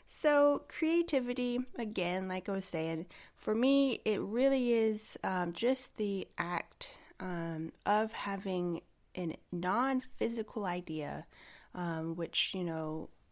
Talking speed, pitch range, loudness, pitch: 120 wpm, 175-250 Hz, -34 LUFS, 205 Hz